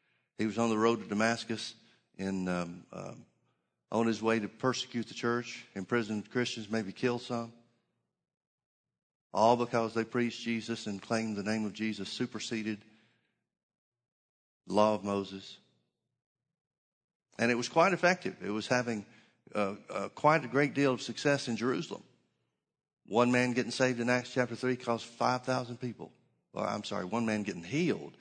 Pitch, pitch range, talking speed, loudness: 115 Hz, 110-125 Hz, 155 wpm, -32 LUFS